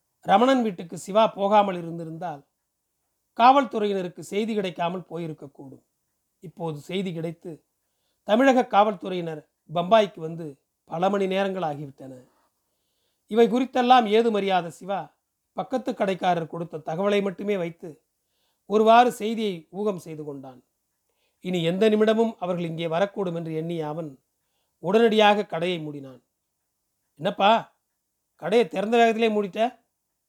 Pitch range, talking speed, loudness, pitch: 165-215 Hz, 105 wpm, -23 LUFS, 190 Hz